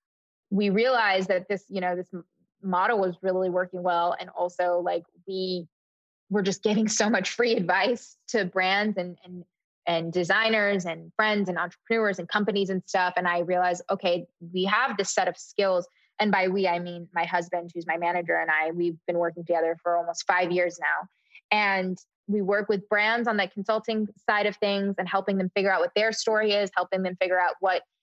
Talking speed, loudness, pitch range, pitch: 200 wpm, -26 LUFS, 175-205 Hz, 185 Hz